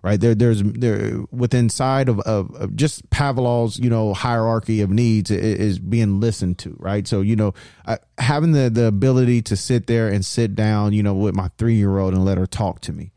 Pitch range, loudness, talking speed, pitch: 100-120 Hz, -19 LUFS, 225 wpm, 110 Hz